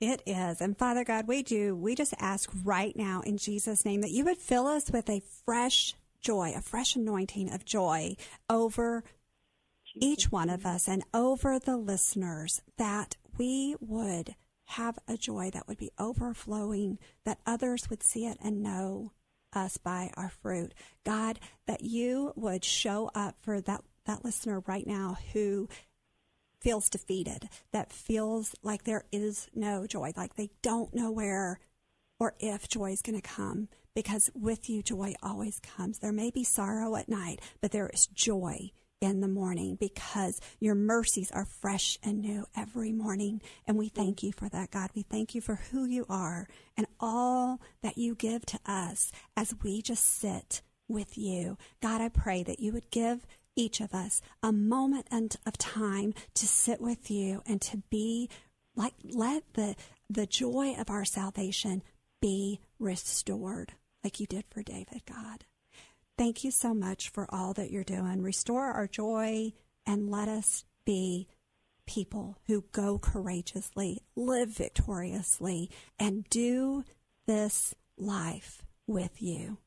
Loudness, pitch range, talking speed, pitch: -33 LUFS, 195-230 Hz, 160 wpm, 210 Hz